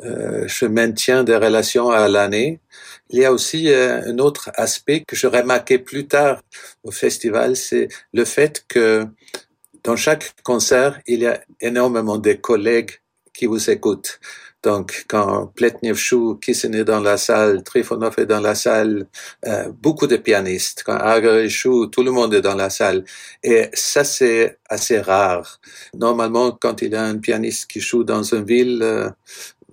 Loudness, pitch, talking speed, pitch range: -17 LUFS, 115 Hz, 170 wpm, 110-125 Hz